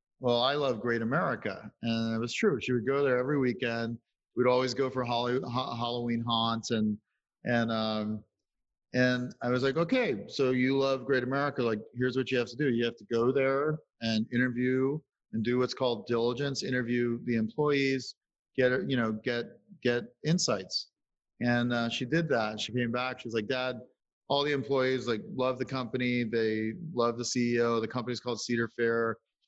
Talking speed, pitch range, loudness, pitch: 185 wpm, 115-130 Hz, -30 LUFS, 125 Hz